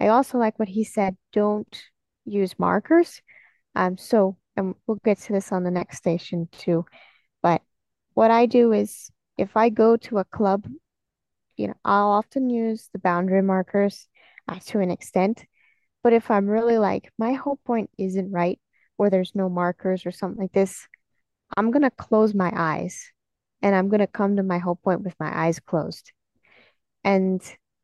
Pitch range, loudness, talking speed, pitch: 185-220 Hz, -23 LUFS, 170 wpm, 200 Hz